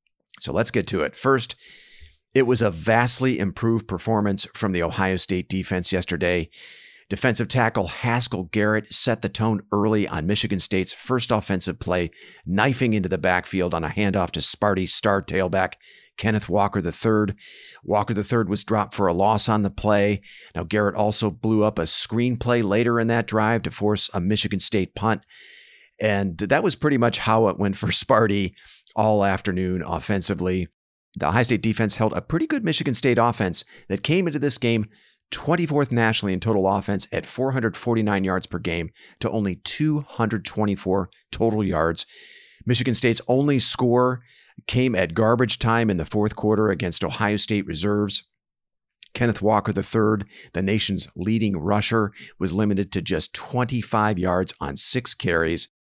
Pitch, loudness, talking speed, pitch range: 105 Hz, -22 LUFS, 160 wpm, 95-115 Hz